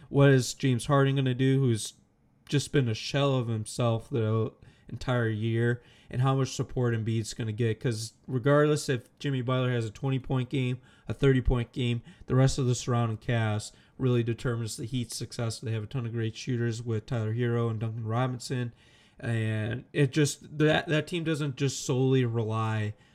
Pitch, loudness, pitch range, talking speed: 125 Hz, -29 LUFS, 115-135 Hz, 185 wpm